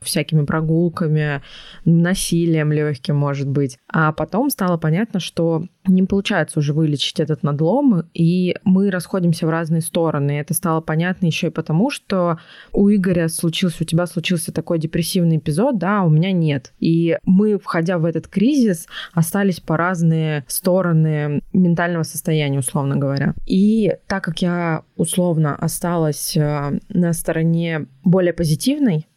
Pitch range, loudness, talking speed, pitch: 155-185 Hz, -18 LUFS, 140 wpm, 170 Hz